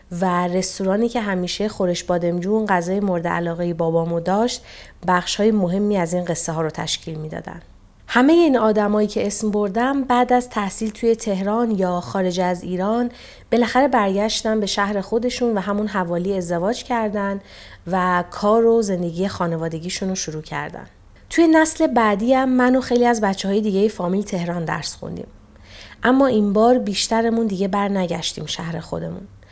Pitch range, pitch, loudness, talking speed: 180-230 Hz, 200 Hz, -20 LUFS, 155 wpm